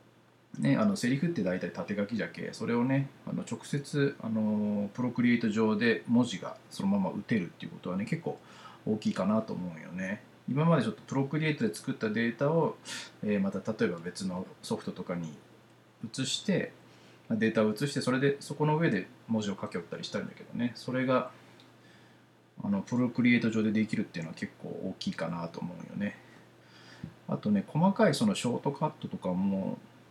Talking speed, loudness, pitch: 350 characters per minute, -31 LUFS, 130 Hz